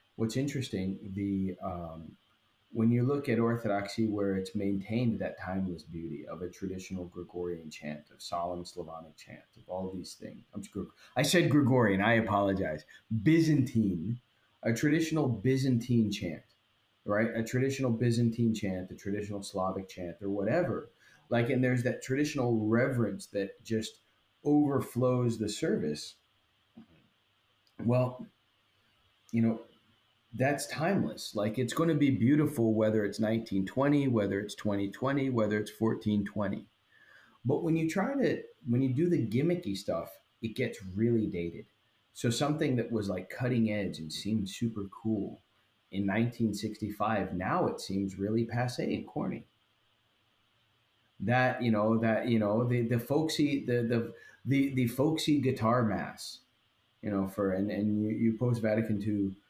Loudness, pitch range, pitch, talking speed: -31 LUFS, 100-125 Hz, 110 Hz, 150 wpm